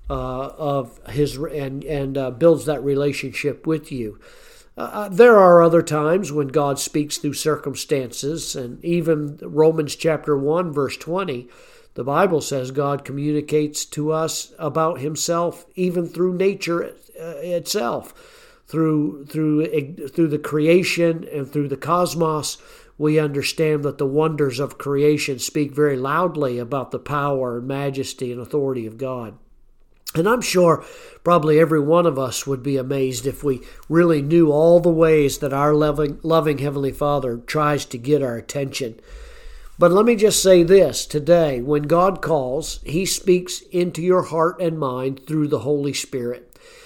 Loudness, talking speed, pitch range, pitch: -20 LUFS, 150 wpm, 140-170 Hz, 150 Hz